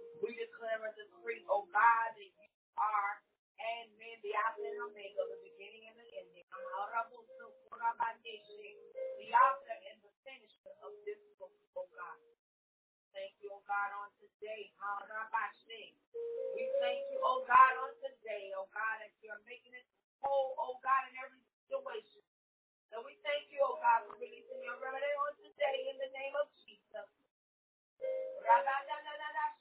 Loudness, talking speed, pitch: -36 LUFS, 165 wpm, 275 Hz